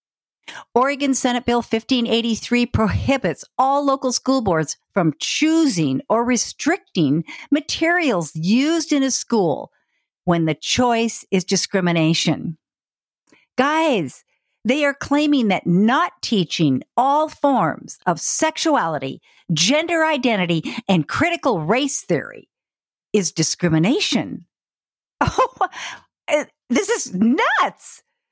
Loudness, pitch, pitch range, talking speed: -19 LUFS, 245 Hz, 180-290 Hz, 95 wpm